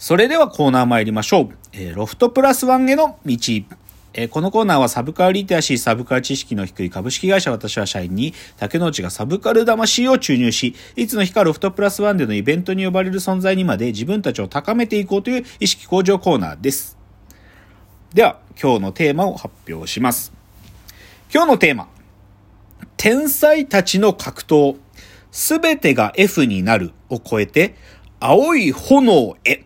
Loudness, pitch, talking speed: -17 LUFS, 140 Hz, 350 characters per minute